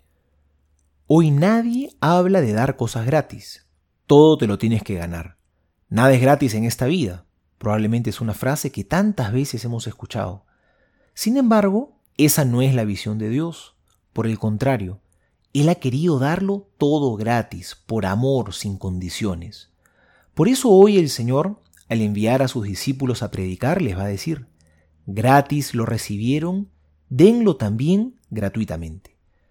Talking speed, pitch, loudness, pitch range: 145 wpm, 115 Hz, -20 LUFS, 100-145 Hz